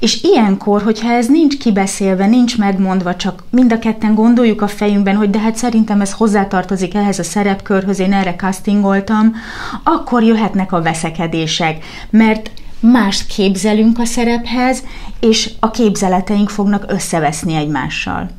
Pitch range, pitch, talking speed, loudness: 190-225 Hz, 205 Hz, 135 wpm, -13 LUFS